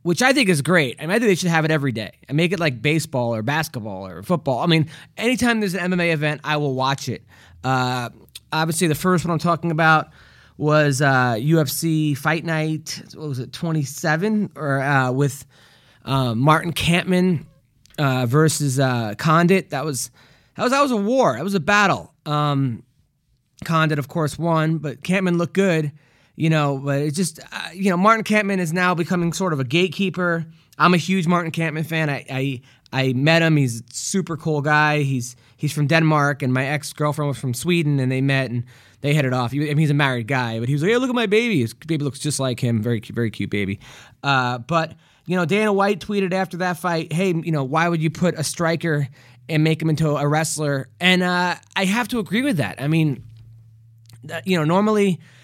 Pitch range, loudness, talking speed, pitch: 130-175 Hz, -20 LUFS, 215 wpm, 155 Hz